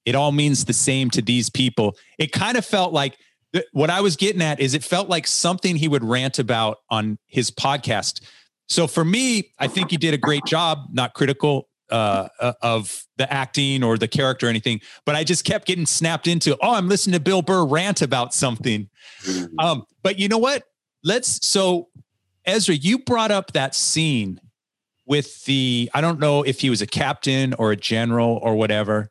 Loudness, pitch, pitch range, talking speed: -20 LUFS, 140 Hz, 120-170 Hz, 200 wpm